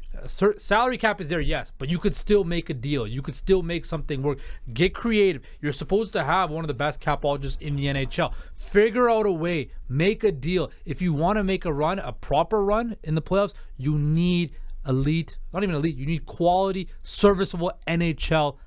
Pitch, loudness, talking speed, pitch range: 170 Hz, -25 LUFS, 205 wpm, 150-195 Hz